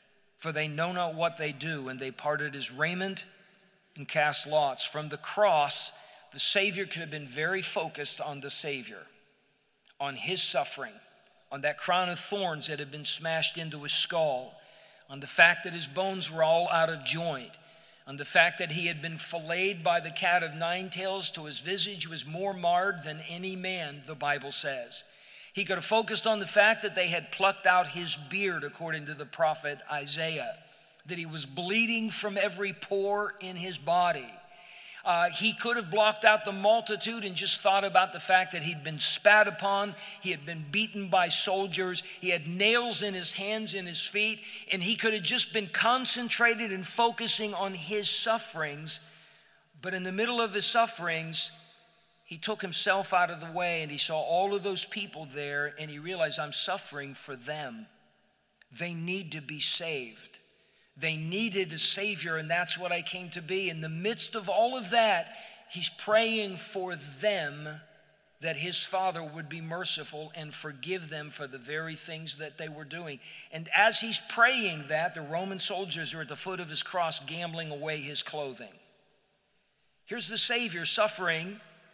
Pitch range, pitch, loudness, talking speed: 155-200 Hz, 175 Hz, -28 LUFS, 185 wpm